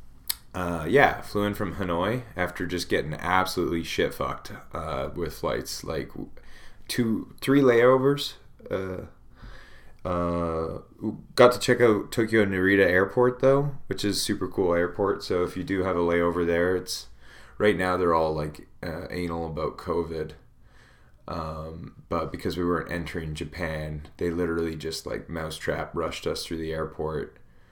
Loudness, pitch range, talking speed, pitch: -26 LUFS, 80-105 Hz, 150 wpm, 90 Hz